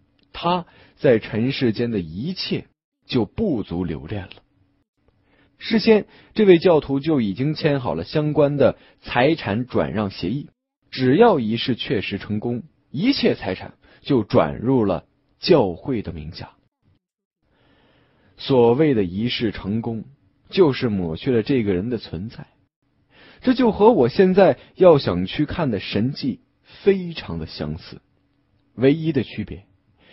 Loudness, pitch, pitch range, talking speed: -20 LUFS, 125 Hz, 105-160 Hz, 195 characters per minute